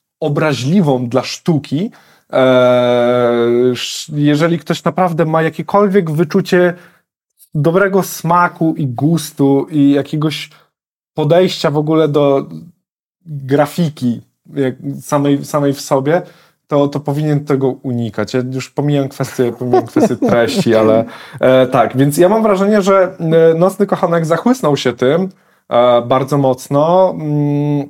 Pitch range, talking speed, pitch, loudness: 135-170 Hz, 105 wpm, 150 Hz, -14 LUFS